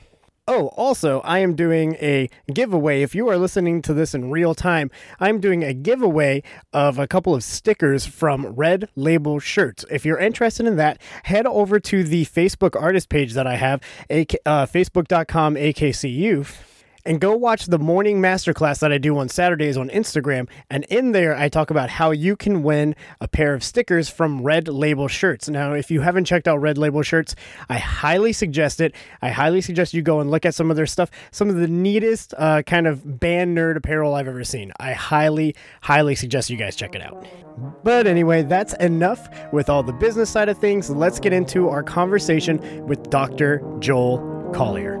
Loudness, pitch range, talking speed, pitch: -20 LUFS, 145-180 Hz, 195 wpm, 160 Hz